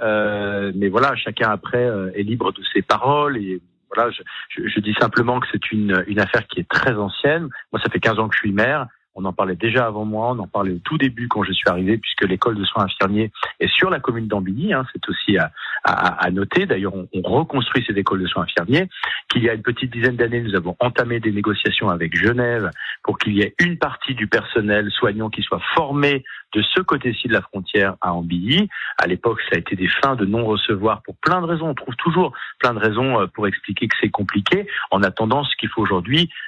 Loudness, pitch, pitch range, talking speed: -19 LUFS, 110 Hz, 100-125 Hz, 230 wpm